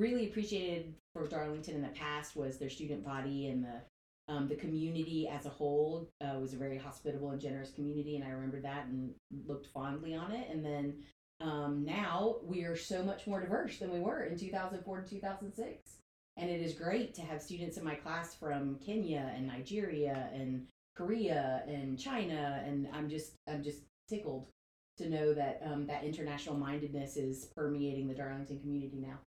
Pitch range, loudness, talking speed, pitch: 140-170 Hz, -40 LUFS, 185 wpm, 150 Hz